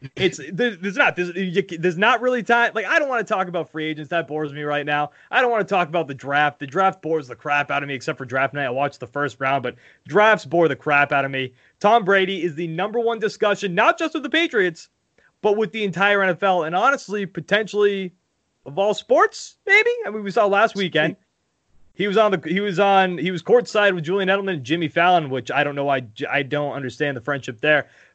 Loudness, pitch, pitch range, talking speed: -20 LUFS, 180 Hz, 145-210 Hz, 235 wpm